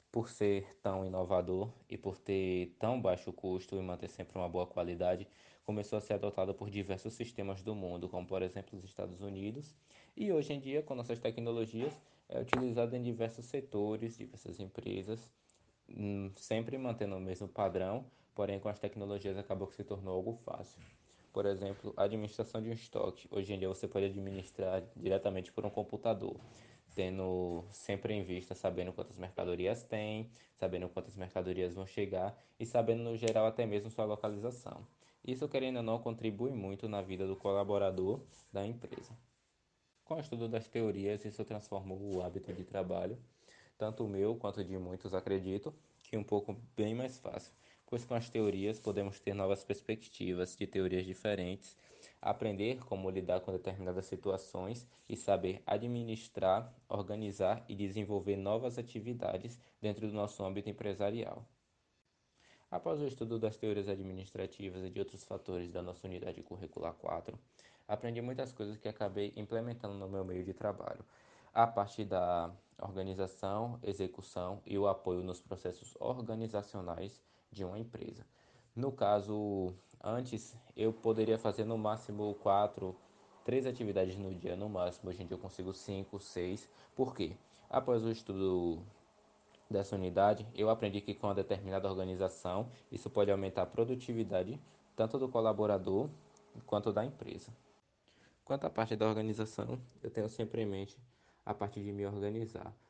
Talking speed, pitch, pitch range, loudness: 155 wpm, 100 Hz, 95-115 Hz, -39 LUFS